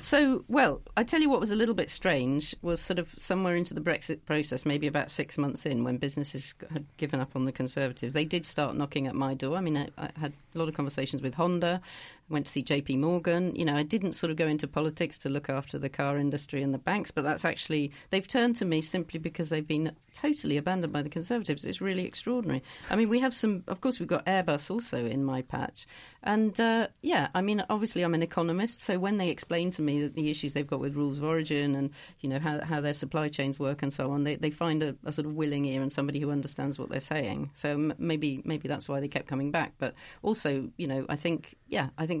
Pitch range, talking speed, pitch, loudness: 140-175 Hz, 250 wpm, 155 Hz, -31 LUFS